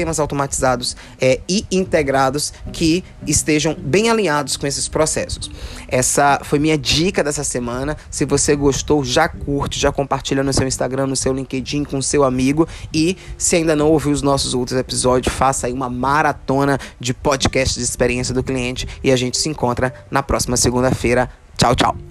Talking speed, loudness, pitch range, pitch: 170 wpm, -18 LUFS, 125-150 Hz, 135 Hz